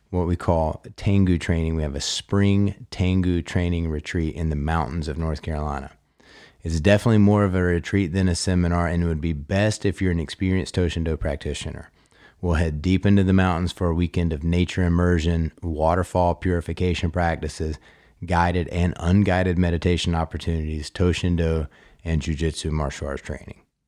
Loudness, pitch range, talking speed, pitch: -23 LUFS, 80-90 Hz, 160 wpm, 85 Hz